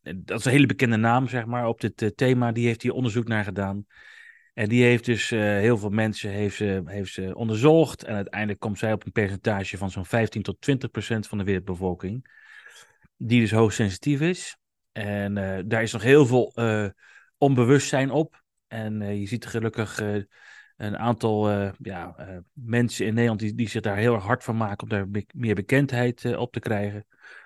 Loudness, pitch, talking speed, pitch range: -24 LUFS, 110 Hz, 205 wpm, 100-120 Hz